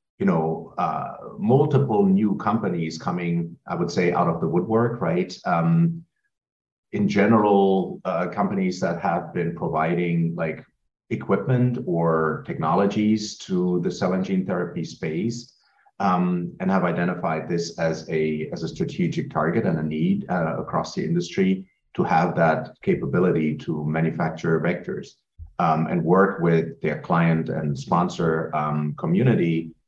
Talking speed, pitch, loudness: 140 wpm, 90 Hz, -23 LUFS